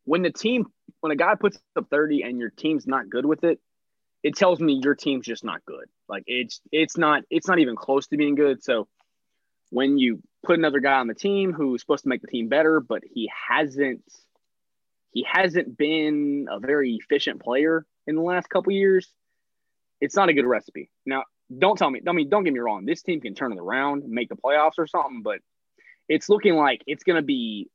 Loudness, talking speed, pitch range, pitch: -23 LUFS, 220 wpm, 135-170 Hz, 150 Hz